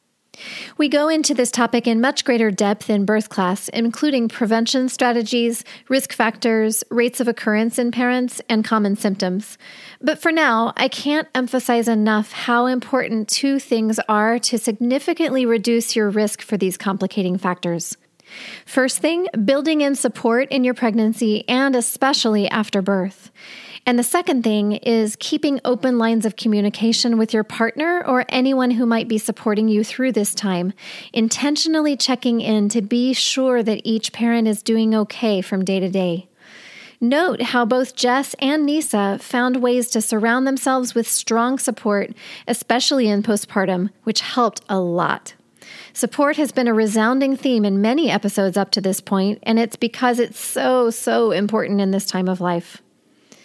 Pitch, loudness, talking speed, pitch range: 230 Hz, -19 LUFS, 160 wpm, 215-255 Hz